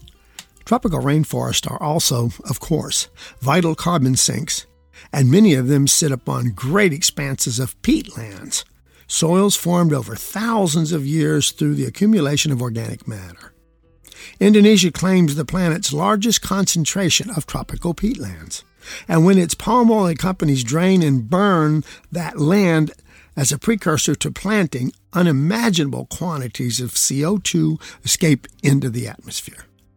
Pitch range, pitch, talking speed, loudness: 130-180 Hz, 155 Hz, 130 wpm, -18 LUFS